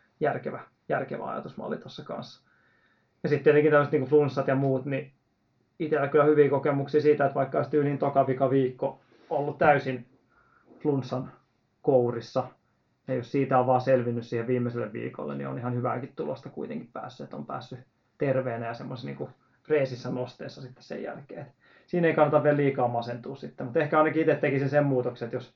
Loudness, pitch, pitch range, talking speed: -27 LUFS, 135 Hz, 125-145 Hz, 170 wpm